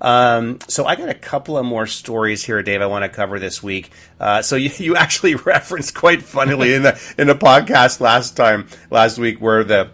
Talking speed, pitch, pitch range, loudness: 215 wpm, 115 Hz, 100-135 Hz, -15 LUFS